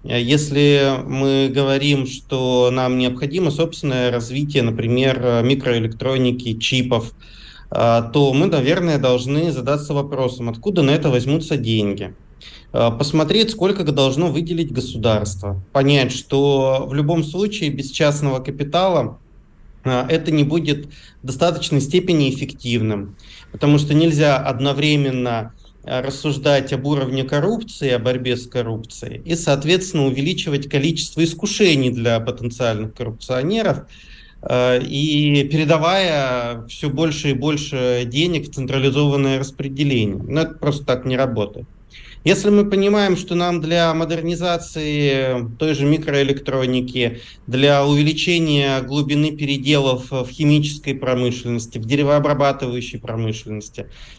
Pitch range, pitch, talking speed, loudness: 125-150 Hz, 140 Hz, 110 wpm, -18 LUFS